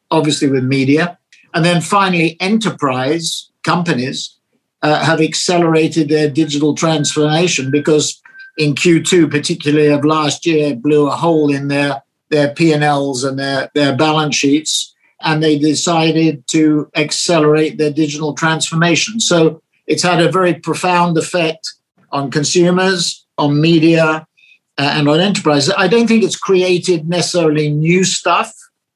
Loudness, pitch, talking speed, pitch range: -14 LUFS, 155 Hz, 135 wpm, 150-170 Hz